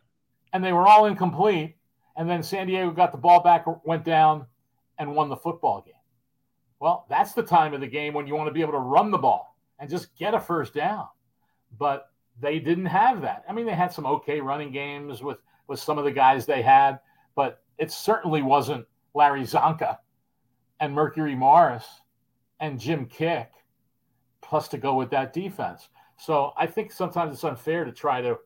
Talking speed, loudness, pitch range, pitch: 190 wpm, -24 LUFS, 140-175 Hz, 155 Hz